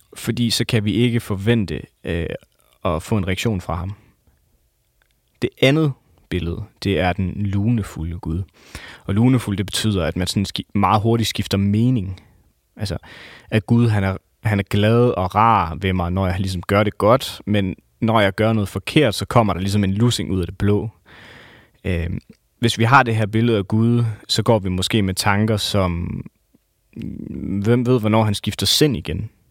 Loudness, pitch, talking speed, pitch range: -19 LUFS, 105 Hz, 180 wpm, 95-115 Hz